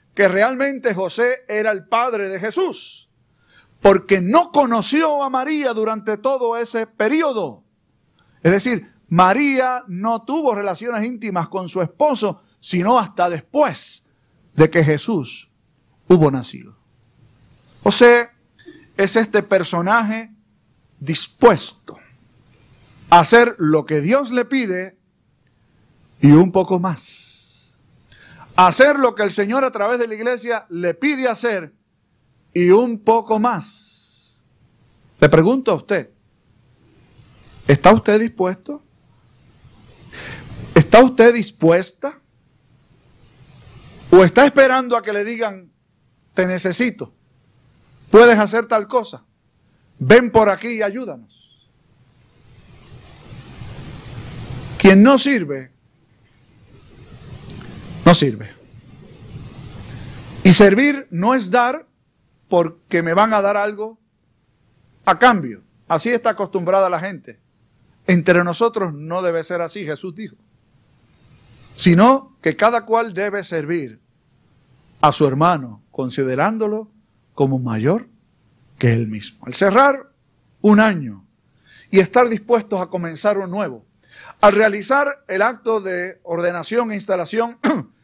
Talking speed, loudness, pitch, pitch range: 110 wpm, -16 LUFS, 185 Hz, 135-225 Hz